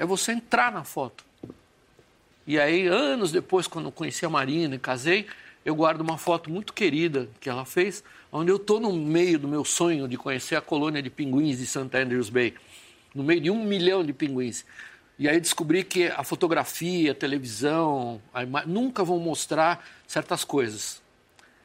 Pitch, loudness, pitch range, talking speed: 160 Hz, -26 LUFS, 135-180 Hz, 180 wpm